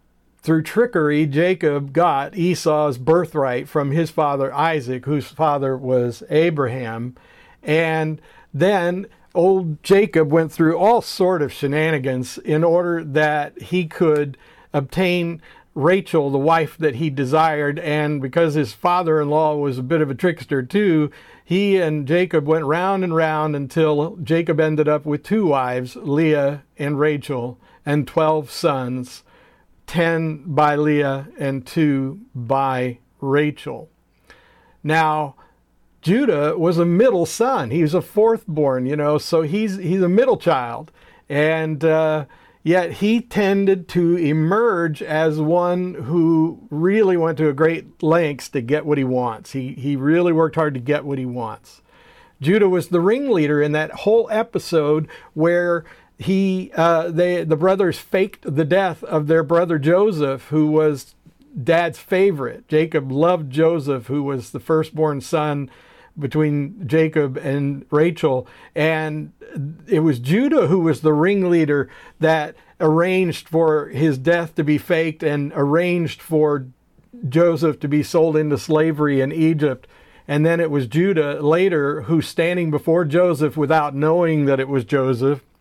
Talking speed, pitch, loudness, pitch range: 145 wpm, 155 Hz, -19 LUFS, 145-170 Hz